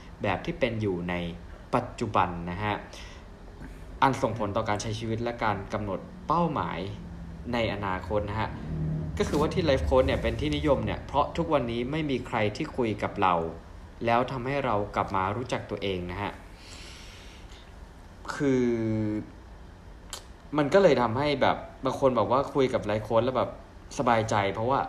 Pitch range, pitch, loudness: 90-120 Hz, 105 Hz, -28 LUFS